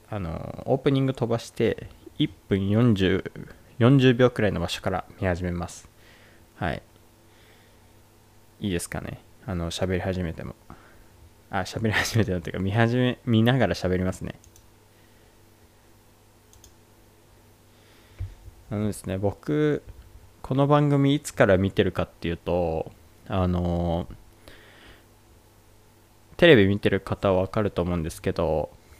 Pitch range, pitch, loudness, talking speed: 90-110 Hz, 105 Hz, -24 LUFS, 230 characters per minute